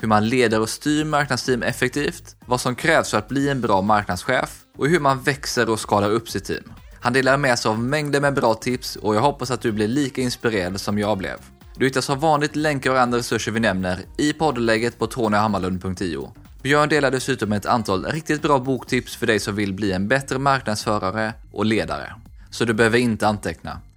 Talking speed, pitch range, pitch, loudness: 205 wpm, 105-135 Hz, 120 Hz, -21 LUFS